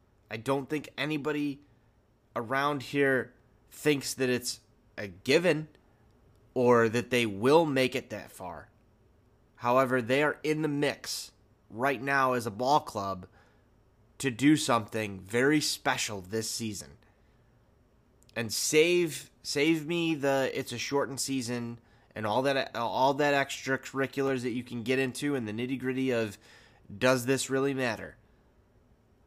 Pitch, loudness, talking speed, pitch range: 125 Hz, -29 LUFS, 135 wpm, 110-135 Hz